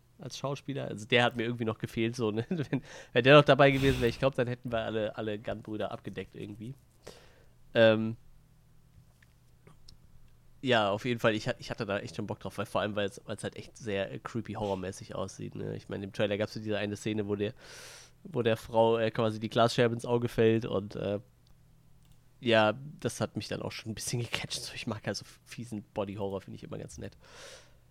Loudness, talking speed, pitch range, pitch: -31 LUFS, 215 wpm, 105-125 Hz, 115 Hz